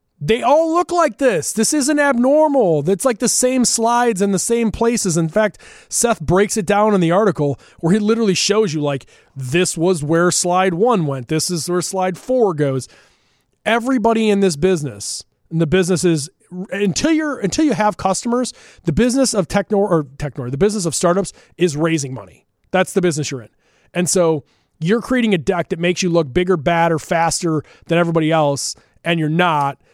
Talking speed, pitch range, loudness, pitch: 190 wpm, 165-225 Hz, -17 LUFS, 185 Hz